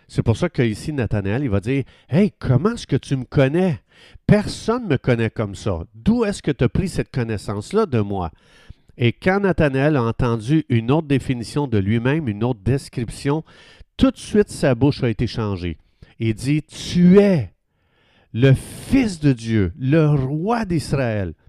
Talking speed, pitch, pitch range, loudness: 180 wpm, 135 Hz, 115-155 Hz, -20 LUFS